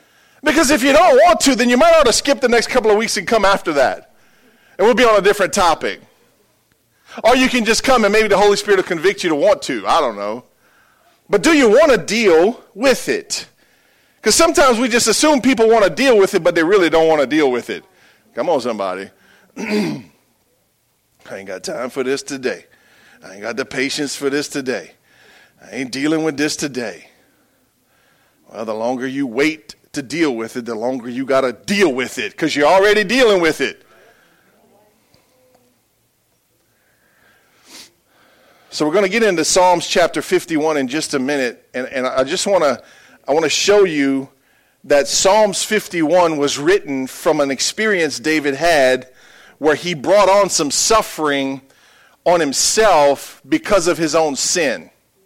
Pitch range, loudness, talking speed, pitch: 140-215 Hz, -15 LUFS, 180 wpm, 170 Hz